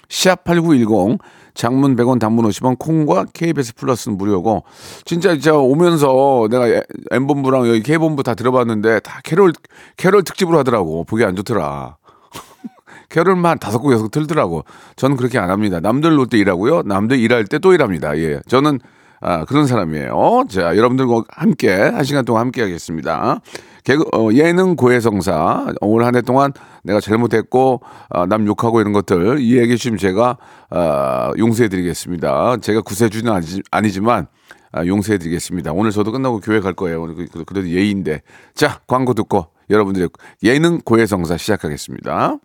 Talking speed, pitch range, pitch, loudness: 350 characters per minute, 100-135 Hz, 115 Hz, -16 LUFS